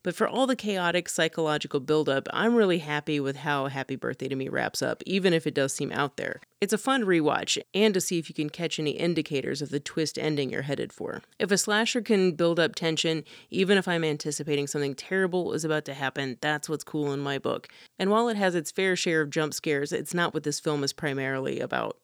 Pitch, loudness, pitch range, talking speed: 155 Hz, -27 LUFS, 145-185 Hz, 235 wpm